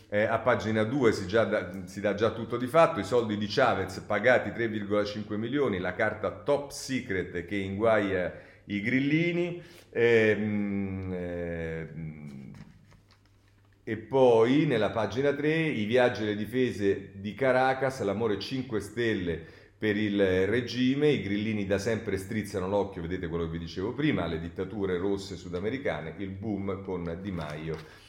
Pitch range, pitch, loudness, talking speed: 95-115 Hz, 105 Hz, -29 LUFS, 145 wpm